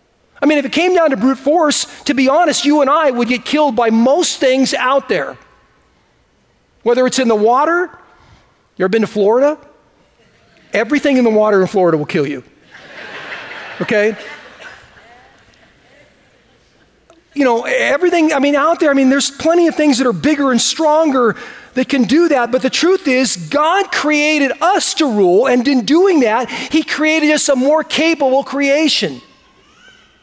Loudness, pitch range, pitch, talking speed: -13 LUFS, 250-305 Hz, 280 Hz, 170 wpm